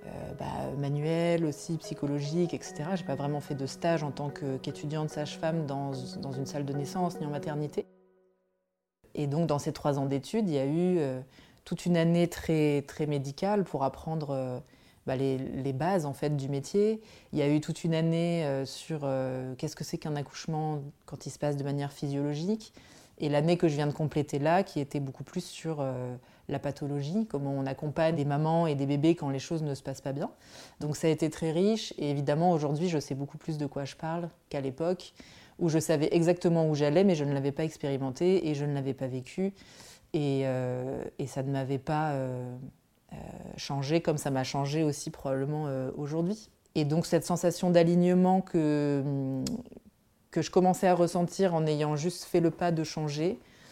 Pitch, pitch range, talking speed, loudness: 150 Hz, 140-170 Hz, 205 wpm, -30 LUFS